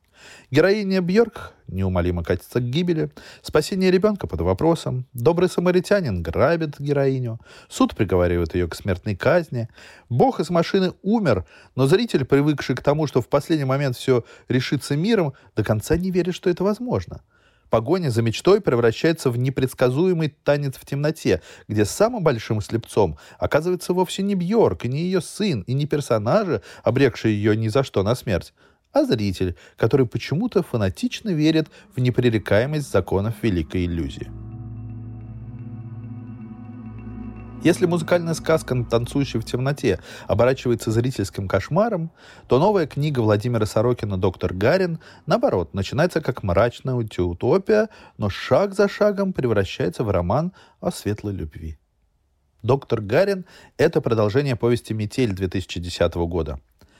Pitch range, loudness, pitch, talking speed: 110-160 Hz, -22 LUFS, 125 Hz, 130 wpm